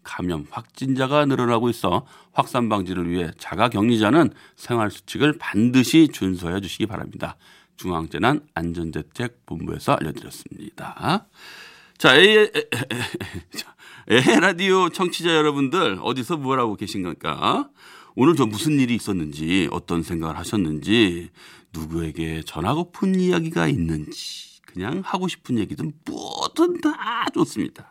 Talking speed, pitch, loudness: 290 characters per minute, 115 Hz, -21 LUFS